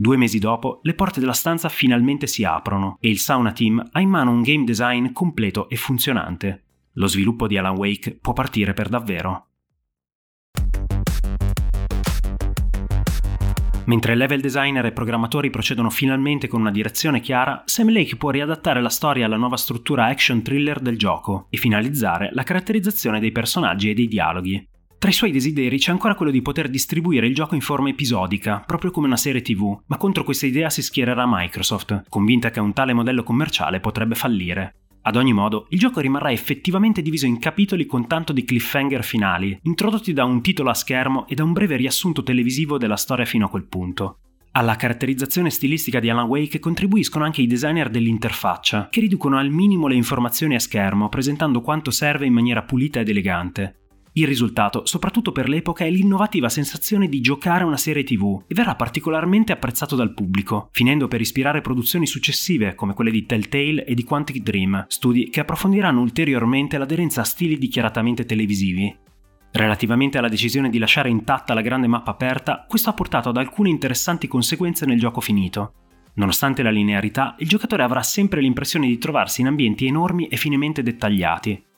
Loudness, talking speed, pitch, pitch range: -20 LUFS, 175 wpm, 125 Hz, 110-145 Hz